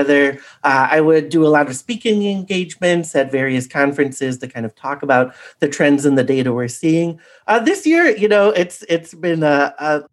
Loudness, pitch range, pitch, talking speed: -16 LUFS, 140-180 Hz, 150 Hz, 200 wpm